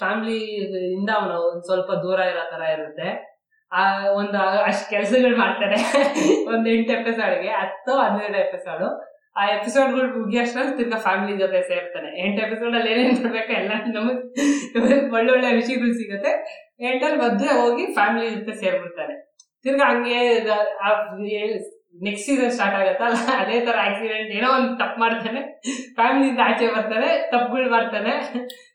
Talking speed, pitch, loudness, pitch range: 130 wpm, 230 Hz, -21 LUFS, 205-260 Hz